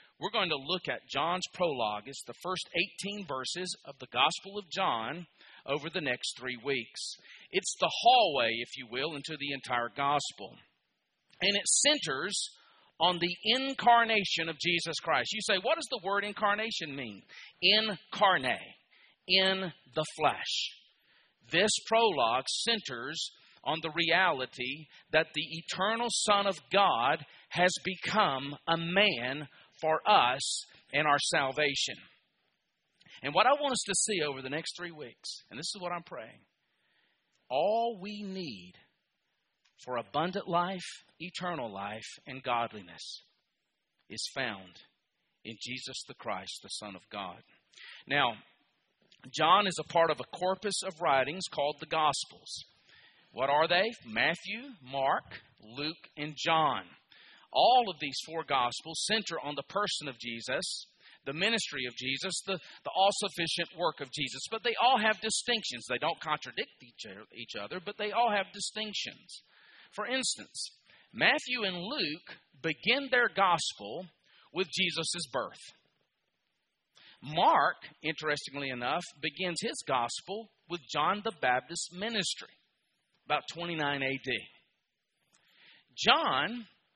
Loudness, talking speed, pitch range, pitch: -31 LUFS, 135 wpm, 145-205 Hz, 170 Hz